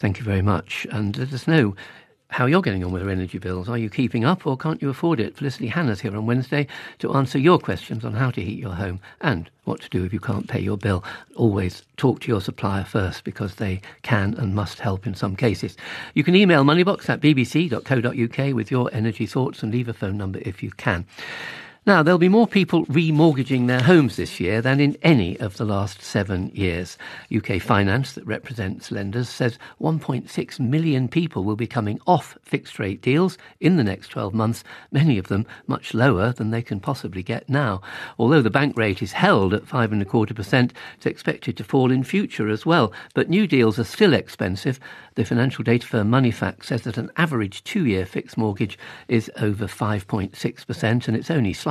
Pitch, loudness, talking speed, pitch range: 115 Hz, -22 LUFS, 215 wpm, 105-135 Hz